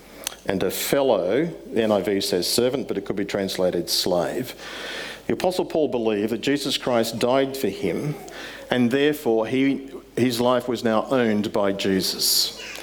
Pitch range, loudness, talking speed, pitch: 105-135 Hz, -23 LUFS, 155 wpm, 115 Hz